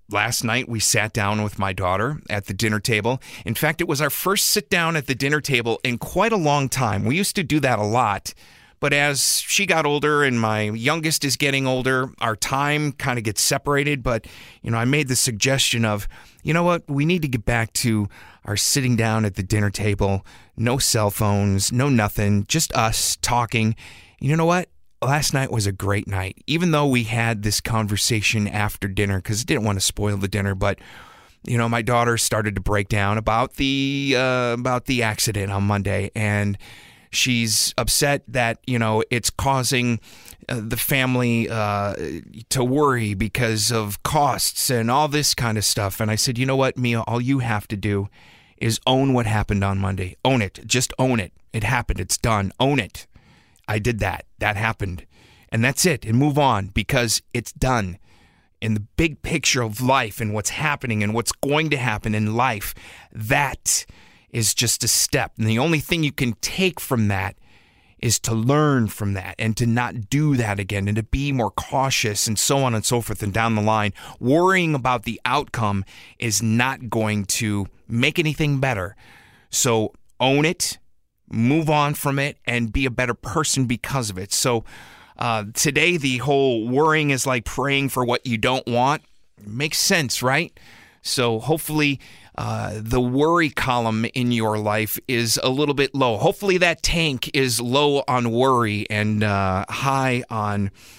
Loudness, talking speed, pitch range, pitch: -21 LUFS, 190 wpm, 105-135 Hz, 120 Hz